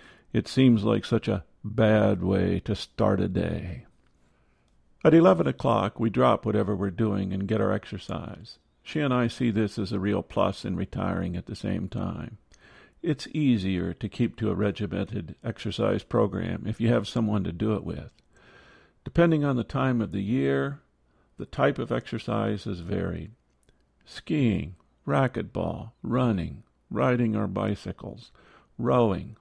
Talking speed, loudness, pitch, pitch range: 155 wpm, -27 LUFS, 105 Hz, 95-115 Hz